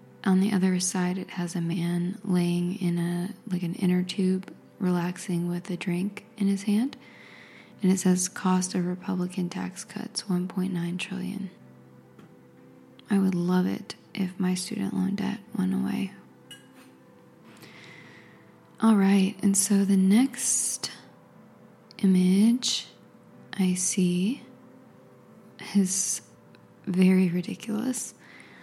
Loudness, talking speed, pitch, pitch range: -26 LUFS, 115 wpm, 185 Hz, 180-200 Hz